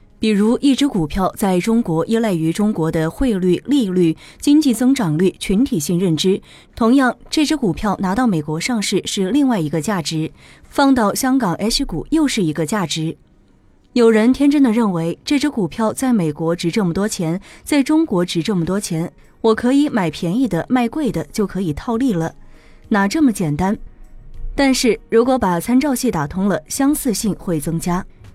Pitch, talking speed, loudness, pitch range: 210 Hz, 265 characters per minute, -17 LUFS, 170-250 Hz